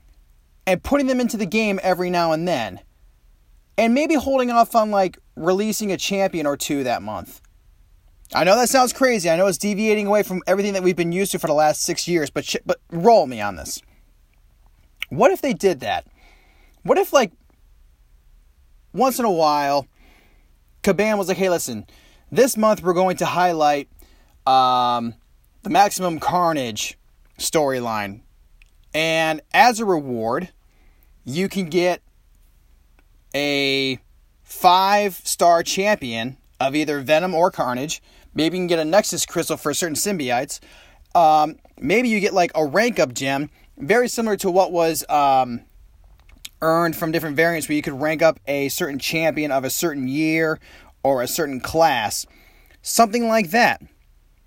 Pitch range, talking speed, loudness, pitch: 115-190 Hz, 160 wpm, -20 LUFS, 160 Hz